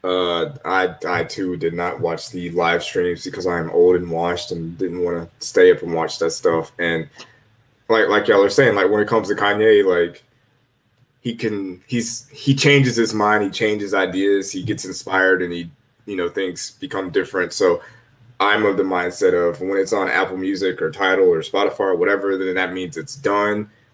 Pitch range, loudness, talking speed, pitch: 90-140 Hz, -19 LUFS, 200 wpm, 105 Hz